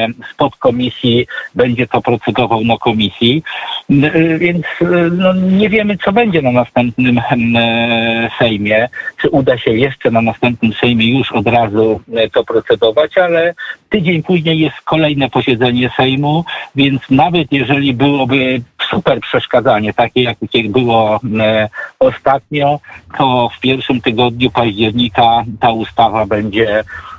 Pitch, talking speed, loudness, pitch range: 125 Hz, 115 wpm, -13 LUFS, 115-150 Hz